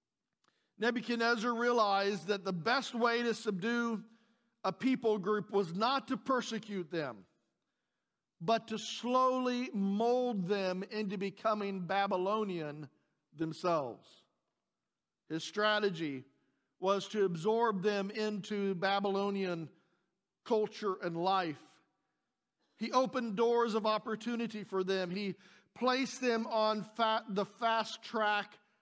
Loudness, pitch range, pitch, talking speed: -34 LUFS, 190-230 Hz, 210 Hz, 105 wpm